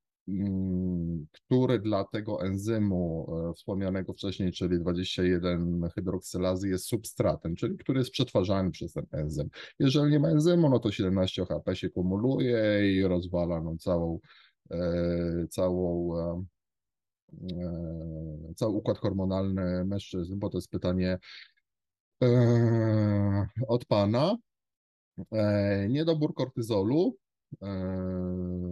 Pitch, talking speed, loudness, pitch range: 95 Hz, 100 wpm, -29 LUFS, 90-110 Hz